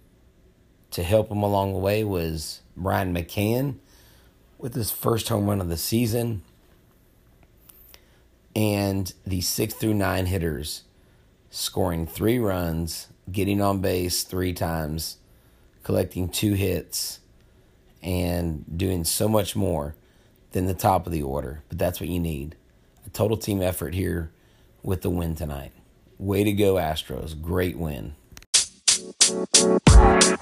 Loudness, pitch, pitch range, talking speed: -24 LUFS, 90 Hz, 80-100 Hz, 125 wpm